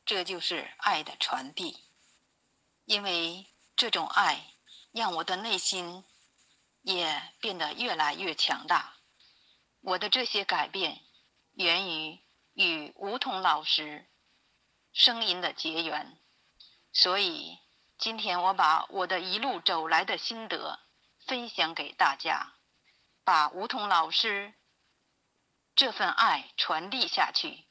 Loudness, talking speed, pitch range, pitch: -28 LUFS, 160 characters per minute, 165-210 Hz, 185 Hz